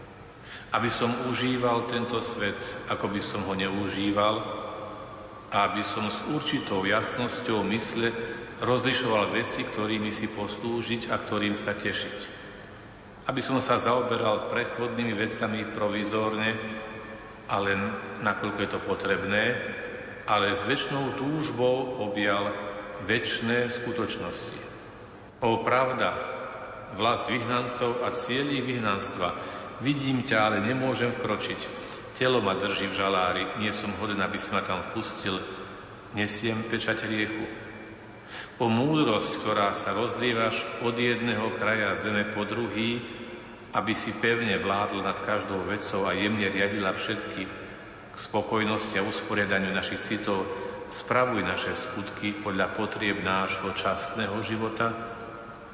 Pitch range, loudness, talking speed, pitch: 100-120 Hz, -28 LUFS, 115 wpm, 110 Hz